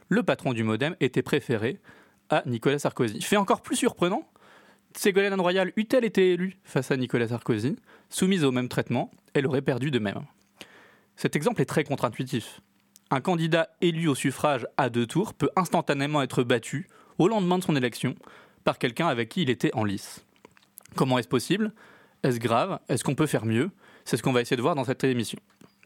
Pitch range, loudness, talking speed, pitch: 125-180 Hz, -26 LUFS, 190 wpm, 145 Hz